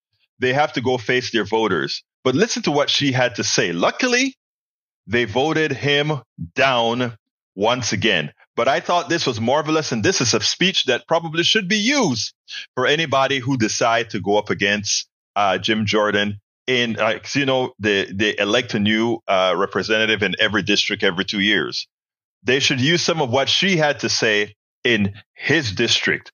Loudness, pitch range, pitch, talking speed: -19 LUFS, 110-155 Hz, 125 Hz, 180 wpm